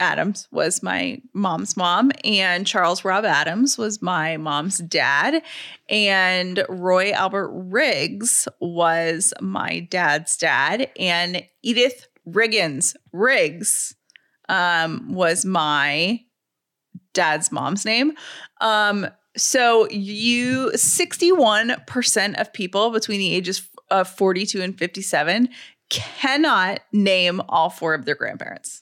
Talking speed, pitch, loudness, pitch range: 105 wpm, 195 Hz, -20 LUFS, 180-230 Hz